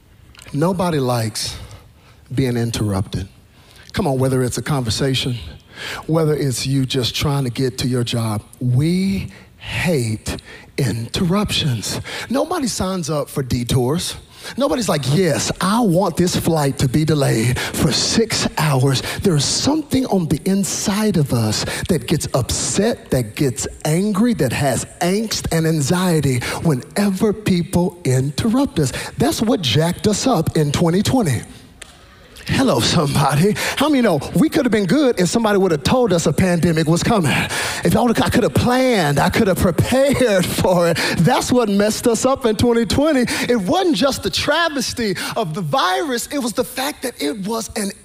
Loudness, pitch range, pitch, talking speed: -18 LUFS, 130-220 Hz, 165 Hz, 160 wpm